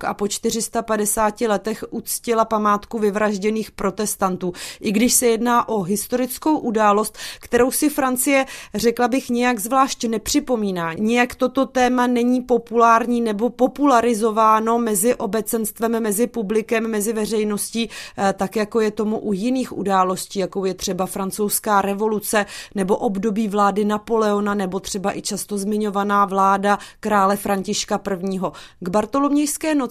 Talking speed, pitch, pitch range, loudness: 130 wpm, 220 Hz, 205-240 Hz, -20 LUFS